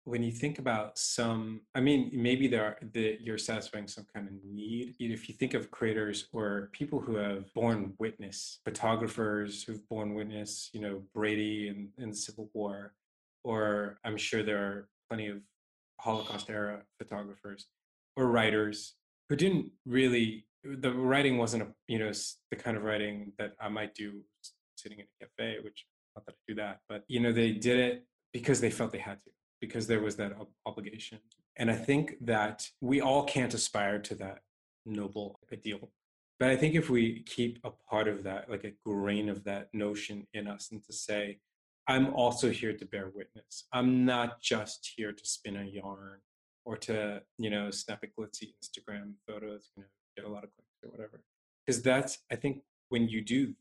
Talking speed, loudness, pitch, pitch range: 195 wpm, -33 LUFS, 110 Hz, 105-120 Hz